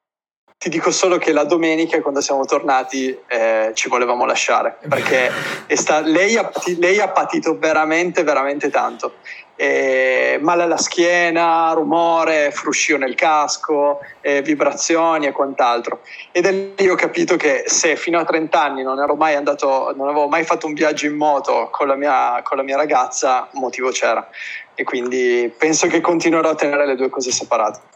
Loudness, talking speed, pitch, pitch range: -17 LUFS, 165 wpm, 155 Hz, 140-170 Hz